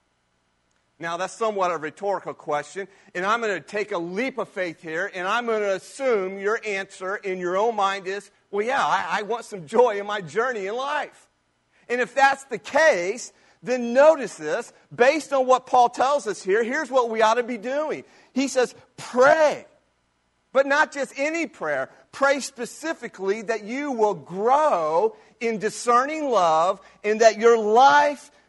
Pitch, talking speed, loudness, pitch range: 225 Hz, 175 wpm, -23 LUFS, 195-270 Hz